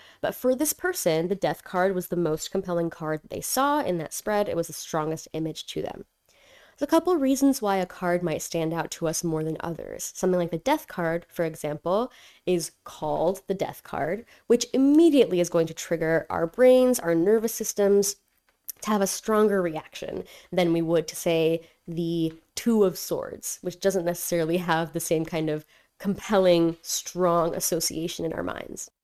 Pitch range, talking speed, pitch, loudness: 165-210 Hz, 190 wpm, 175 Hz, -26 LUFS